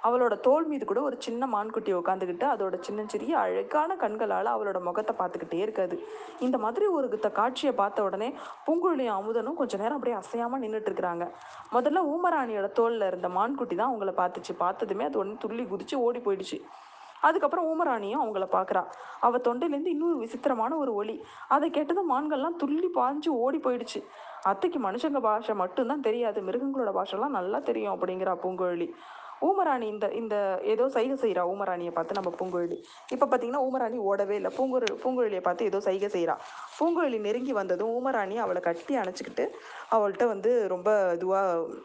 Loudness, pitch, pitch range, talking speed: -29 LUFS, 235 Hz, 200-285 Hz, 150 wpm